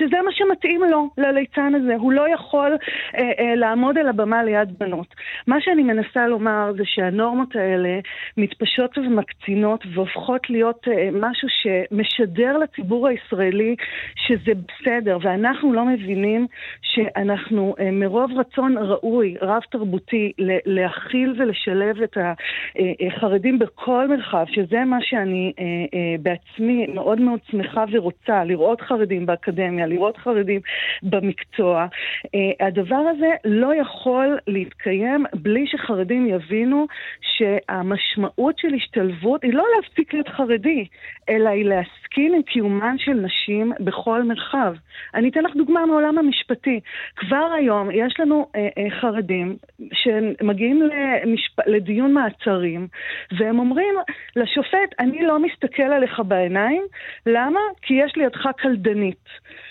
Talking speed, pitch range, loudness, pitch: 120 wpm, 200-270 Hz, -20 LUFS, 230 Hz